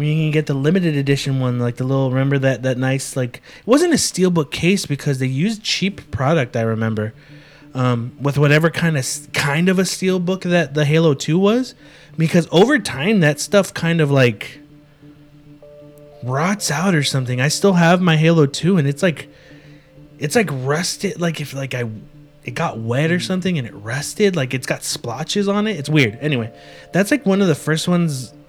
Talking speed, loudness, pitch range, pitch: 200 wpm, -18 LUFS, 135-175 Hz, 150 Hz